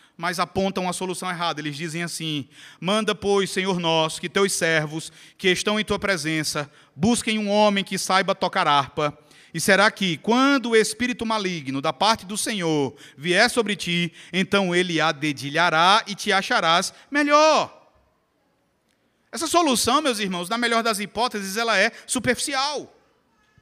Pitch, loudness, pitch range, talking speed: 190 Hz, -22 LUFS, 165-220 Hz, 150 wpm